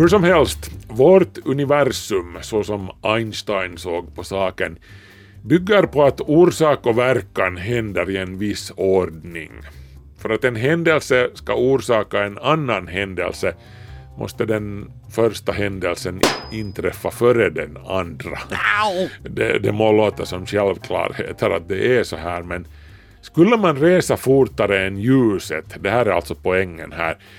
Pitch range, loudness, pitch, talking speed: 95-125 Hz, -19 LUFS, 105 Hz, 140 wpm